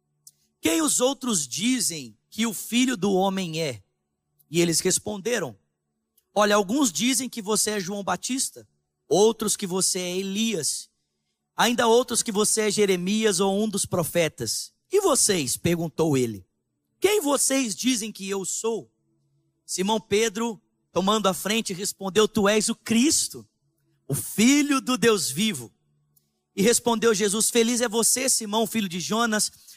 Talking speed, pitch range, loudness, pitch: 145 wpm, 155-230 Hz, -23 LUFS, 200 Hz